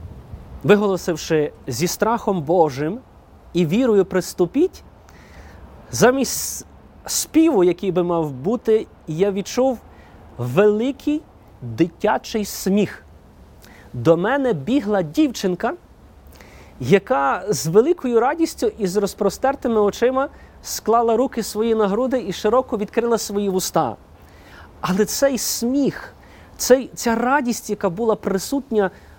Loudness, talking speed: -20 LUFS, 100 wpm